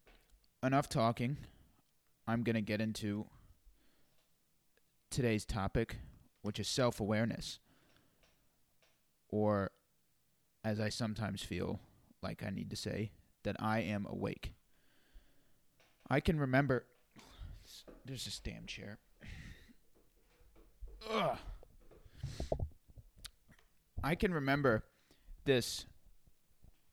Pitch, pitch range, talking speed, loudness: 110 Hz, 105-125 Hz, 85 wpm, -38 LUFS